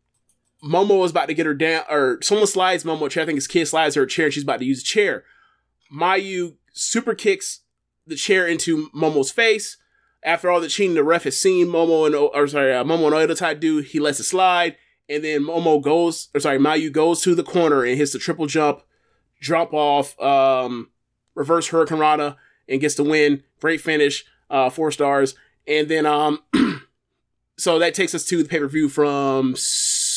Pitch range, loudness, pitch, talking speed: 145-170 Hz, -19 LUFS, 155 Hz, 195 wpm